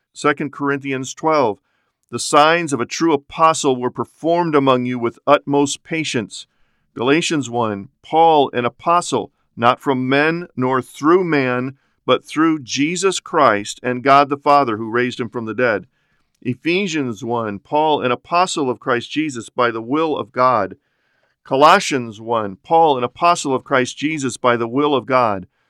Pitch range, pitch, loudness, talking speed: 120-155 Hz, 135 Hz, -17 LUFS, 155 wpm